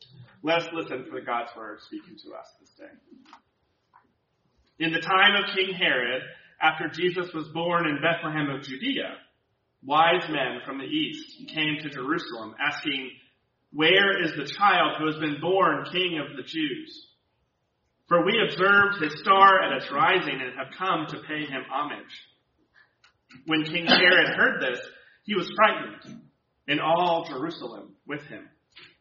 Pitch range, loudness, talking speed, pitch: 150-200 Hz, -24 LUFS, 155 wpm, 165 Hz